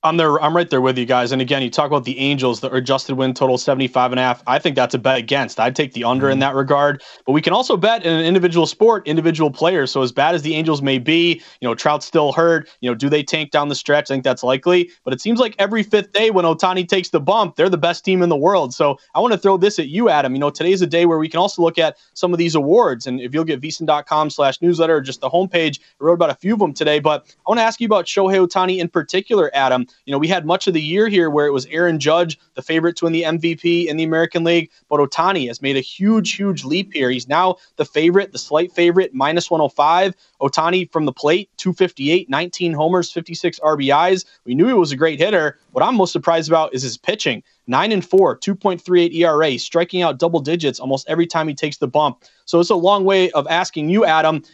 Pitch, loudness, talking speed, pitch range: 160 Hz, -17 LUFS, 260 wpm, 145-180 Hz